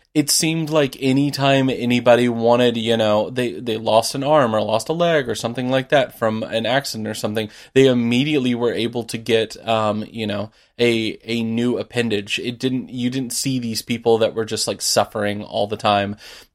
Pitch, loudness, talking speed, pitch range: 120 Hz, -19 LUFS, 195 wpm, 110-130 Hz